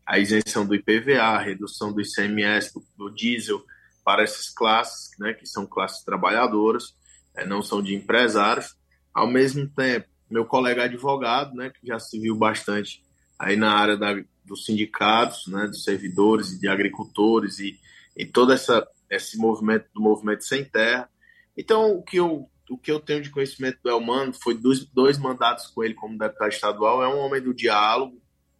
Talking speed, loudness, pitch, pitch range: 175 wpm, -23 LUFS, 110 Hz, 105-130 Hz